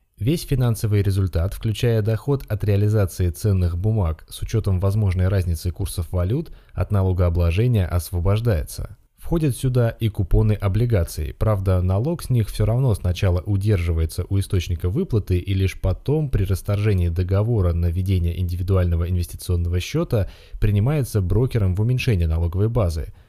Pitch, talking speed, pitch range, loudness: 100 Hz, 130 wpm, 90-110 Hz, -22 LUFS